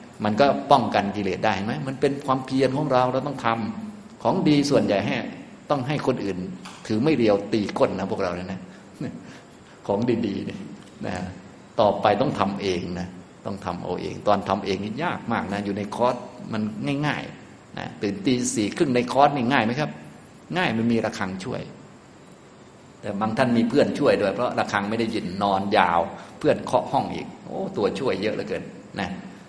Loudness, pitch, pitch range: -24 LUFS, 115 Hz, 100-140 Hz